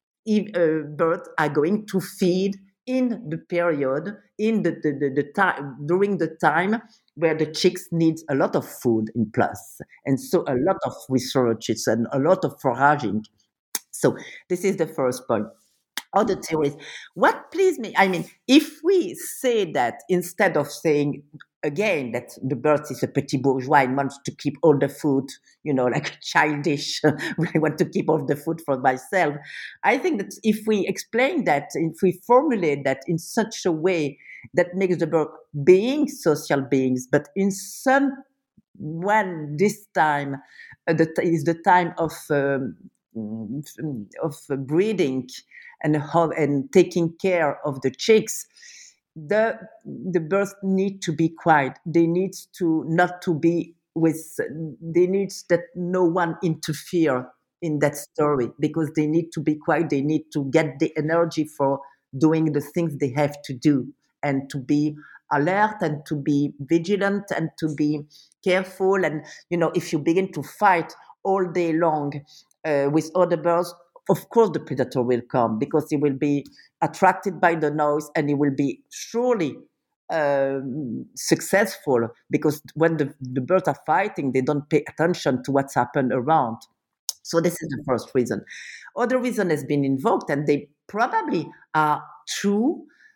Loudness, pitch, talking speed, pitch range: -23 LUFS, 160 Hz, 165 wpm, 145-185 Hz